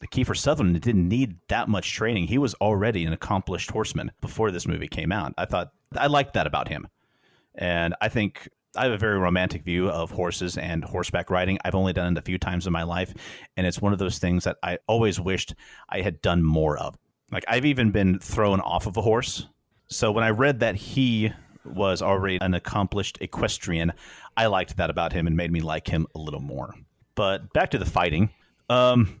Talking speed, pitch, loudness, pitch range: 215 wpm, 95 Hz, -25 LUFS, 85-110 Hz